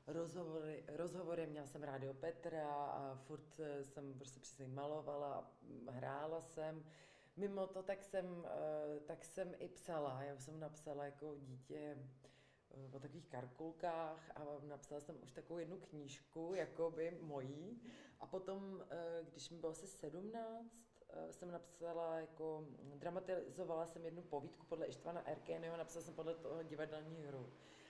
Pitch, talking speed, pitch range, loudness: 160 Hz, 140 wpm, 145-170 Hz, -50 LUFS